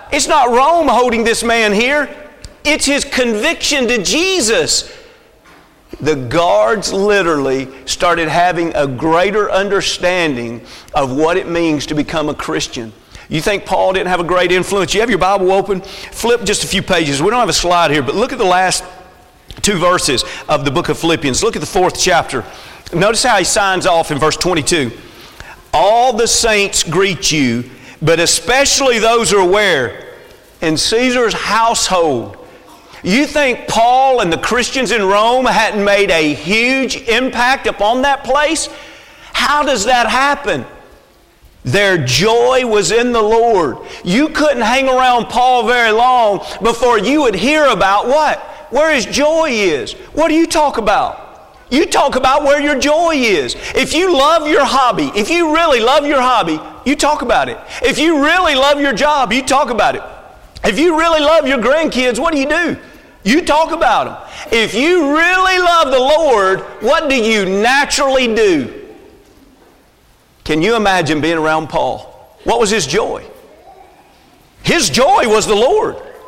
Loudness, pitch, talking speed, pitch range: -13 LUFS, 235 Hz, 165 wpm, 185-295 Hz